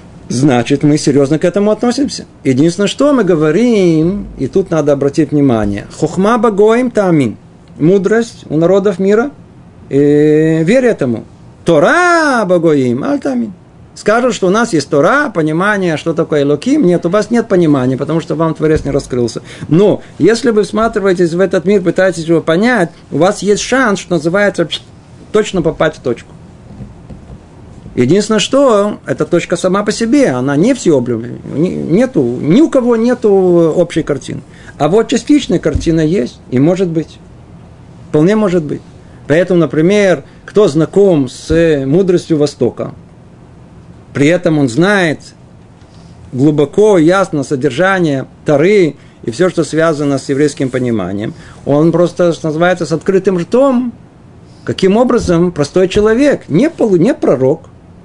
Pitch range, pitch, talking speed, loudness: 150-205 Hz, 175 Hz, 140 wpm, -12 LUFS